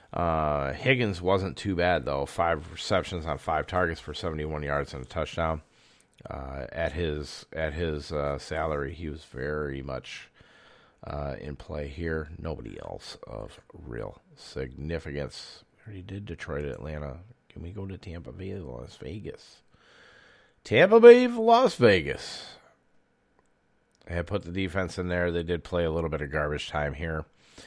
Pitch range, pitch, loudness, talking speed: 75-90 Hz, 80 Hz, -27 LUFS, 155 wpm